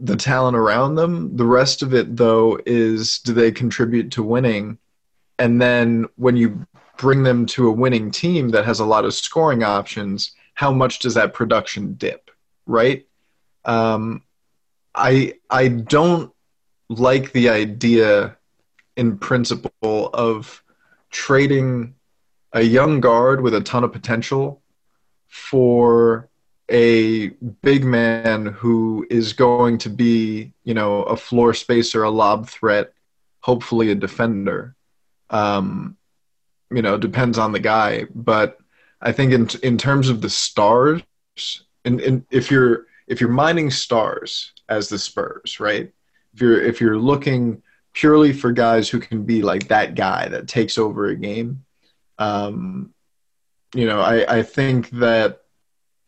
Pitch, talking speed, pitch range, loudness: 120 Hz, 140 wpm, 110-130 Hz, -18 LUFS